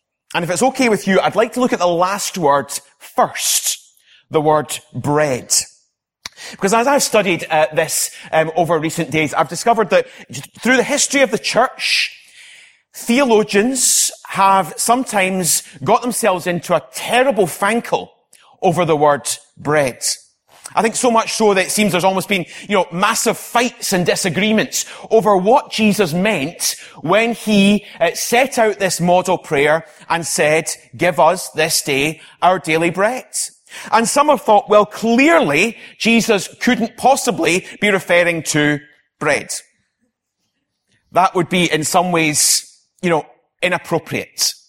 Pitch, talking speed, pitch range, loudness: 190 Hz, 145 wpm, 160-225 Hz, -16 LUFS